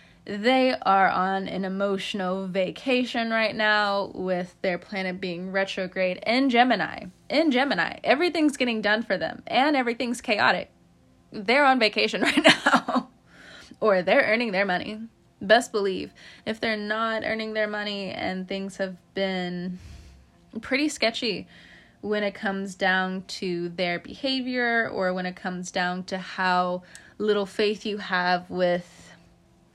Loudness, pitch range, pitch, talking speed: -25 LUFS, 185-235 Hz, 205 Hz, 135 wpm